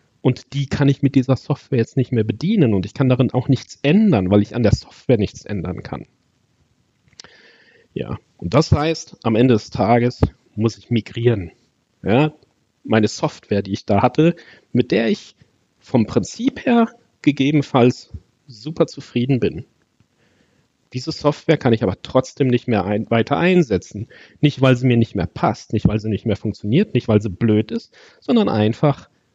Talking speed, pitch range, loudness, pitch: 175 wpm, 110-145 Hz, -19 LUFS, 125 Hz